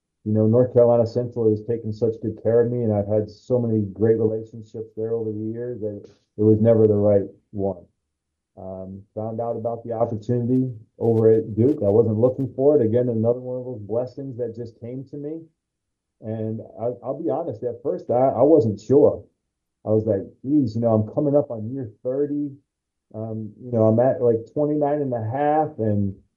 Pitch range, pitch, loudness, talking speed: 110-125 Hz, 115 Hz, -22 LUFS, 205 wpm